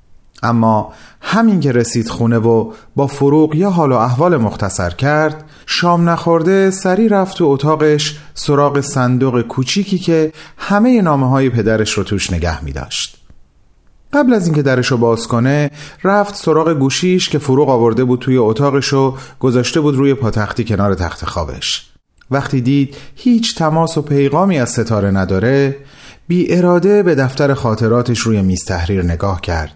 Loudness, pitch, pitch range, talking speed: -14 LUFS, 135 Hz, 110-160 Hz, 155 wpm